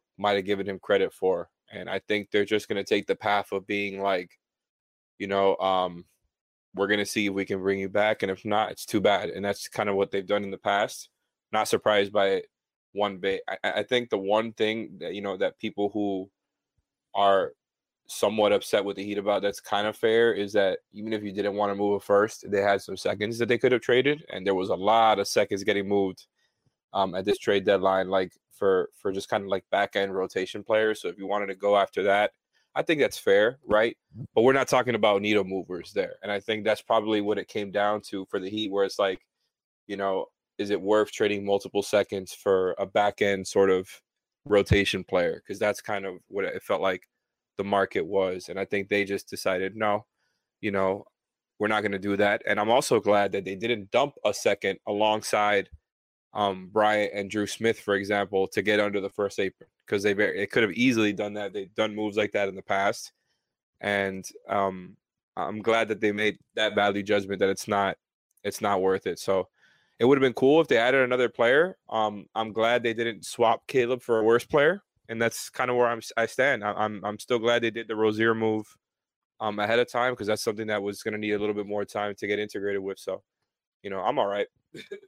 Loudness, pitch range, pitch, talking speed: -26 LUFS, 100-110 Hz, 105 Hz, 230 wpm